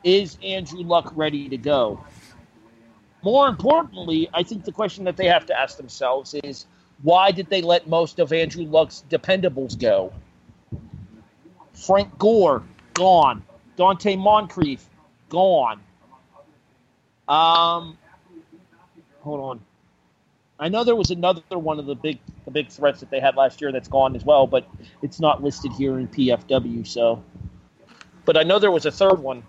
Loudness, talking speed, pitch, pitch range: -20 LUFS, 155 wpm, 155 Hz, 135-180 Hz